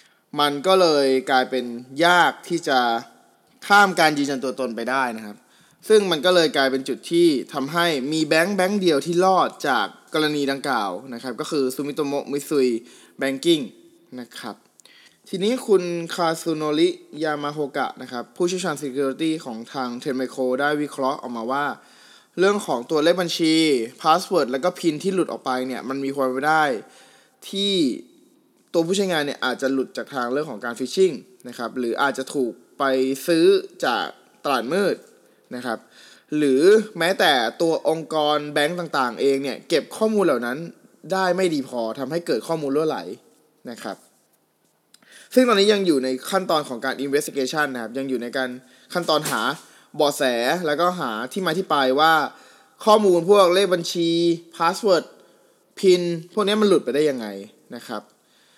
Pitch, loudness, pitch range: 155 Hz, -21 LUFS, 130-185 Hz